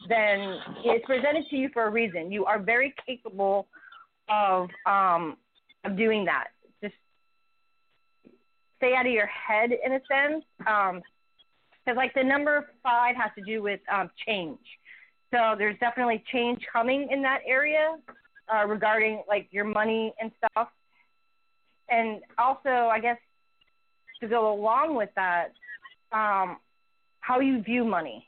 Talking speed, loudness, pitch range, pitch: 140 wpm, -26 LUFS, 215-275 Hz, 235 Hz